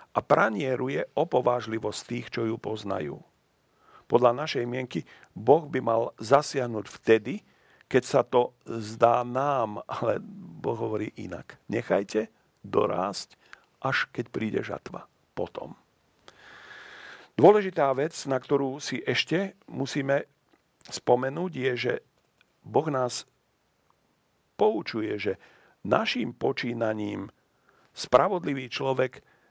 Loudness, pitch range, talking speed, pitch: -27 LUFS, 115-140 Hz, 100 wpm, 125 Hz